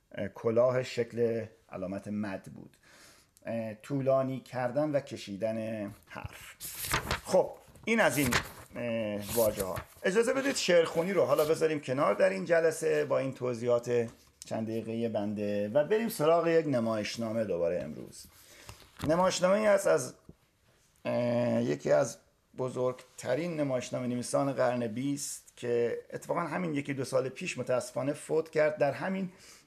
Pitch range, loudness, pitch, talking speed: 115-165 Hz, -31 LUFS, 130 Hz, 125 wpm